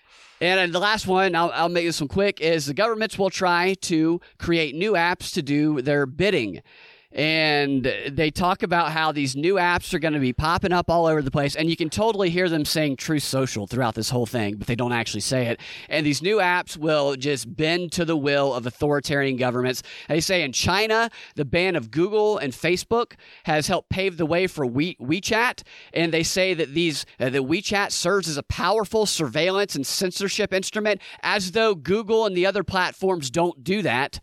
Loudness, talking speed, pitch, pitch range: -22 LUFS, 205 wpm, 165 Hz, 145-190 Hz